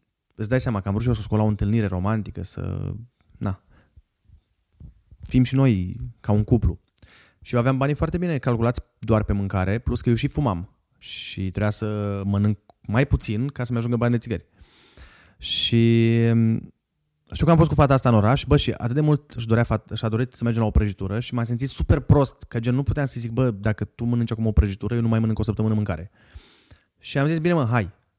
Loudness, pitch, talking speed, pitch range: -23 LUFS, 110 Hz, 220 wpm, 100-120 Hz